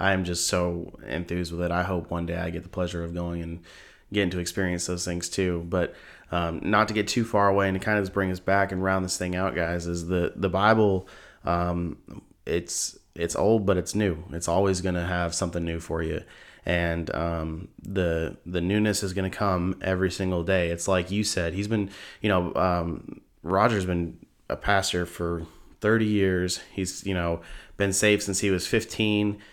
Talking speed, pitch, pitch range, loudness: 205 wpm, 90 Hz, 85-100 Hz, -26 LUFS